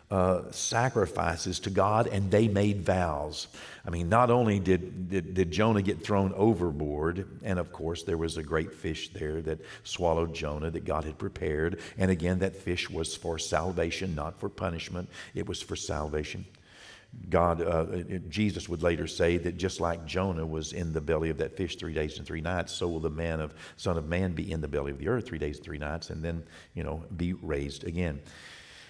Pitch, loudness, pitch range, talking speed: 85 Hz, -31 LUFS, 80-95 Hz, 205 wpm